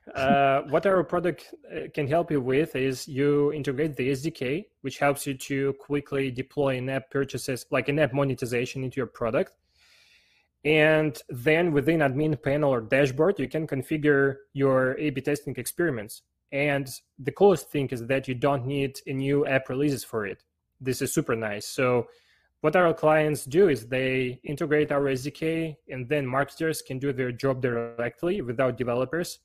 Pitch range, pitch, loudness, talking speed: 130-150 Hz, 140 Hz, -26 LUFS, 170 wpm